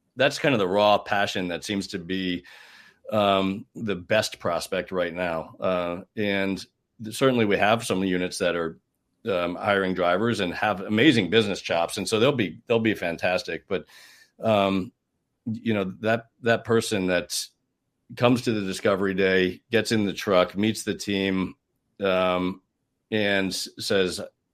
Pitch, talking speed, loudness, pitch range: 100 Hz, 155 wpm, -25 LUFS, 95-110 Hz